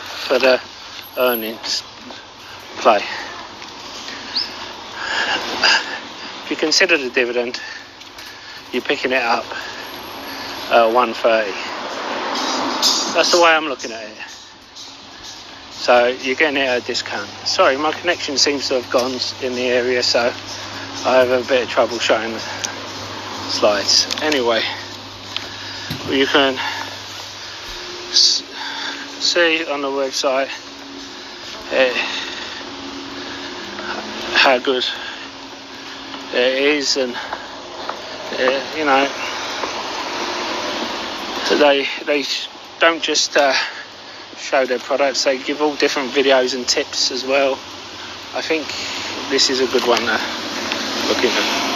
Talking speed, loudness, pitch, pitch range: 105 wpm, -18 LUFS, 135 Hz, 125-150 Hz